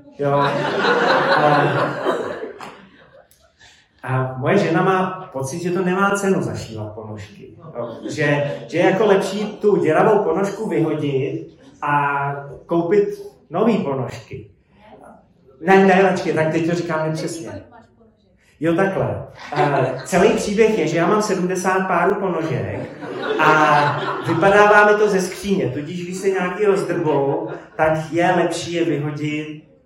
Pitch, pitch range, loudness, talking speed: 165 Hz, 145-190 Hz, -18 LUFS, 125 wpm